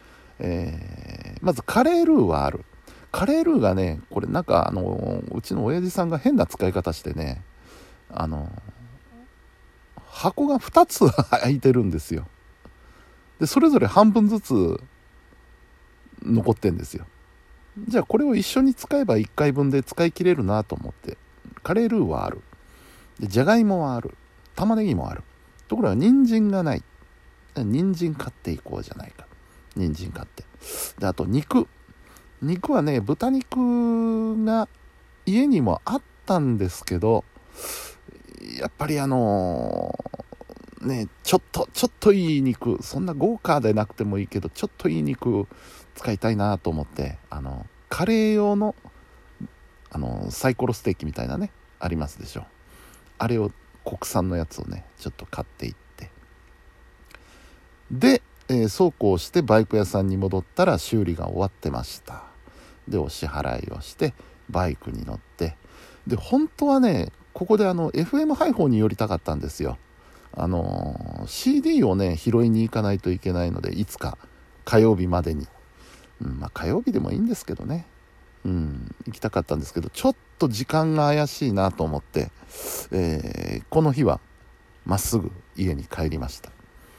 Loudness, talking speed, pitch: -23 LUFS, 295 characters per minute, 115 Hz